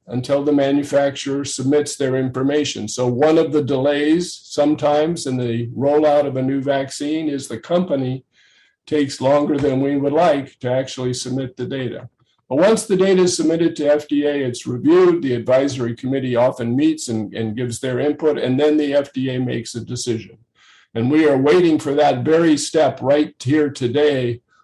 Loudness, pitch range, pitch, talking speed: -18 LUFS, 125-150 Hz, 140 Hz, 175 wpm